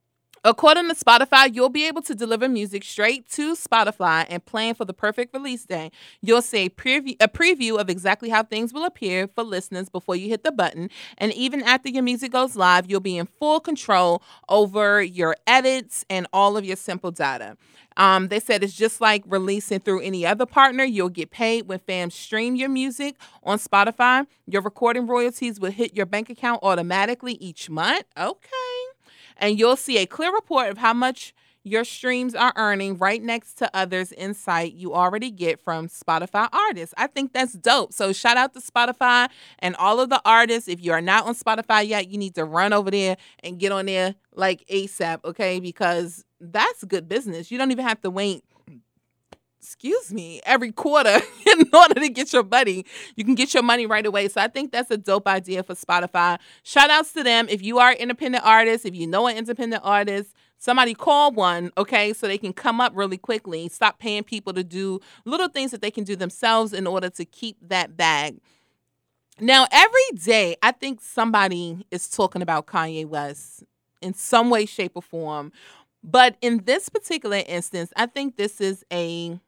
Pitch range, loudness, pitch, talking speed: 185-250 Hz, -20 LUFS, 215 Hz, 195 wpm